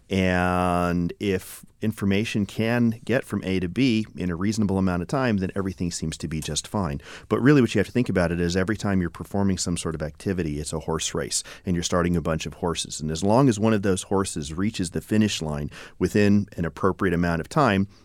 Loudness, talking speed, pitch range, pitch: -24 LUFS, 230 wpm, 85-105 Hz, 95 Hz